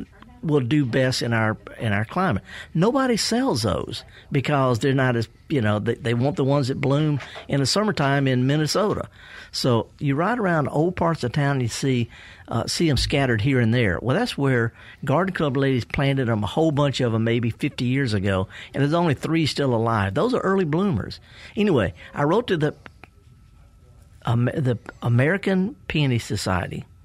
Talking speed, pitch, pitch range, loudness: 185 wpm, 135 Hz, 115-150 Hz, -22 LUFS